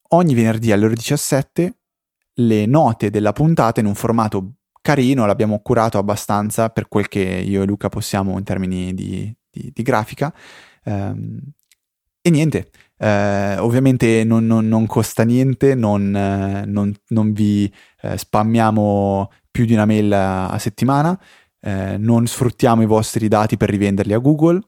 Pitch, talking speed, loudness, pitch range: 110 Hz, 140 wpm, -17 LUFS, 100-120 Hz